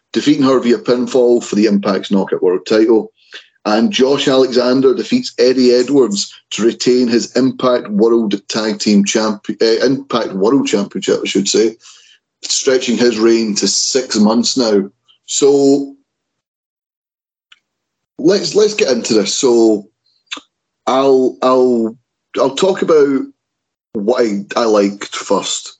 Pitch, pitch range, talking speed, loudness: 125 Hz, 110-135 Hz, 130 wpm, -13 LUFS